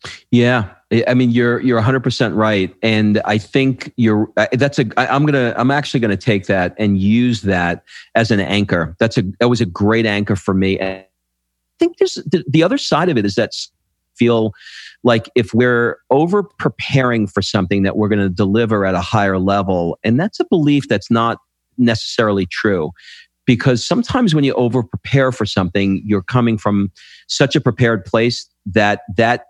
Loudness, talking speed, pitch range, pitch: -16 LUFS, 185 wpm, 100-125 Hz, 115 Hz